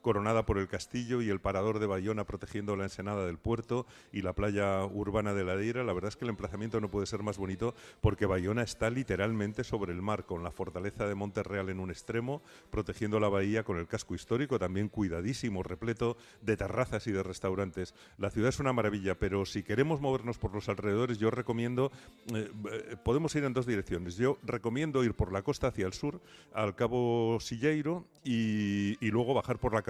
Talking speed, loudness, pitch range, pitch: 200 wpm, -34 LUFS, 100-120 Hz, 105 Hz